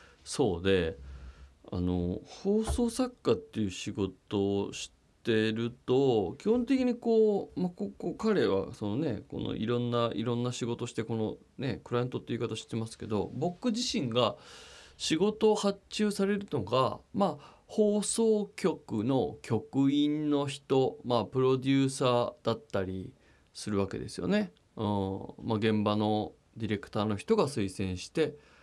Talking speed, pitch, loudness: 300 characters per minute, 120 Hz, -31 LUFS